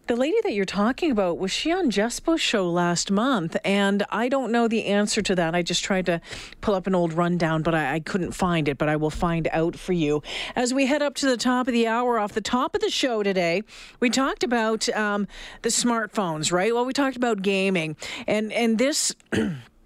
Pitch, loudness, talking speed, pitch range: 210 Hz, -23 LUFS, 225 wpm, 175-245 Hz